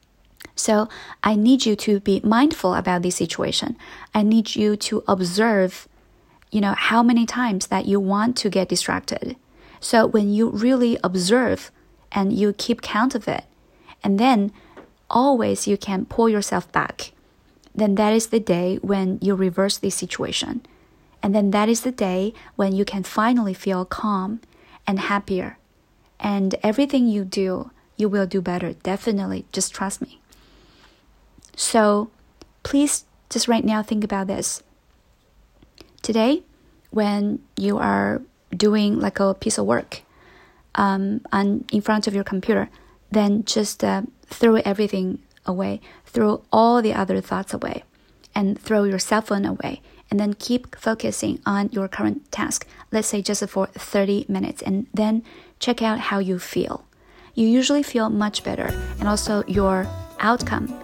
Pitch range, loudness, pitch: 195-225 Hz, -21 LUFS, 210 Hz